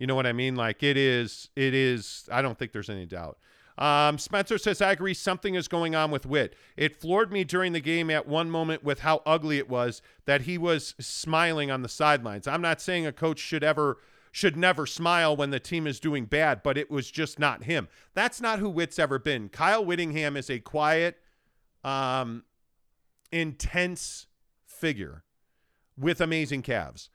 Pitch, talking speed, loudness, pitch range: 150 Hz, 190 wpm, -27 LUFS, 135-170 Hz